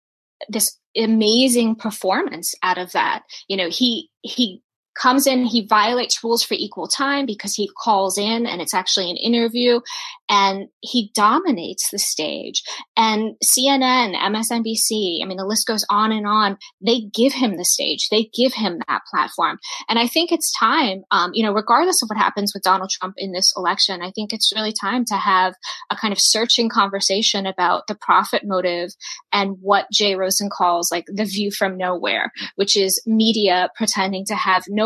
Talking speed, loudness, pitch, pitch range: 180 wpm, -18 LUFS, 215 Hz, 195-235 Hz